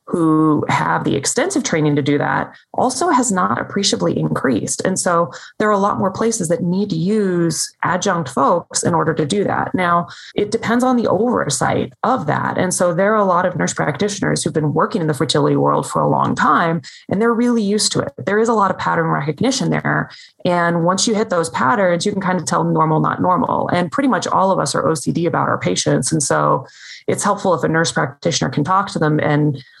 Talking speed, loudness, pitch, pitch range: 230 wpm, -17 LUFS, 180 Hz, 160-210 Hz